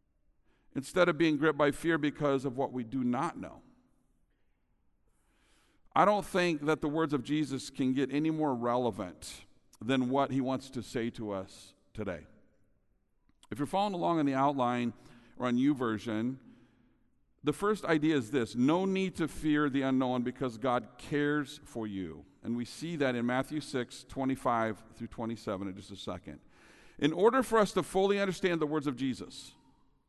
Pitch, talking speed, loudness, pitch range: 135 Hz, 170 wpm, -32 LUFS, 120-155 Hz